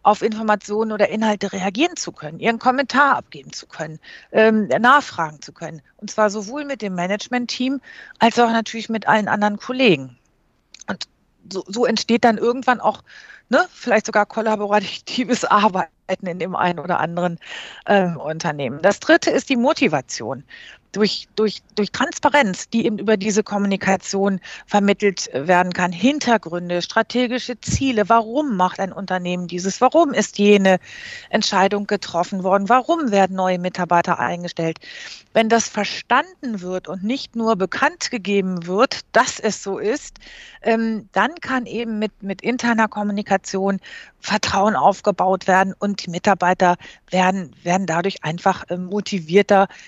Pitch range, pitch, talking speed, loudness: 185-235 Hz, 205 Hz, 140 wpm, -19 LUFS